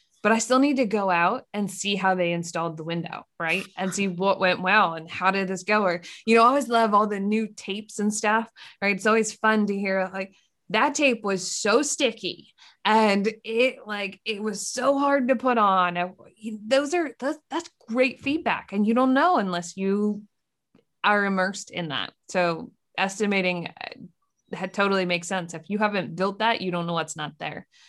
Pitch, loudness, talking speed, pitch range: 205 Hz, -24 LUFS, 195 wpm, 185-225 Hz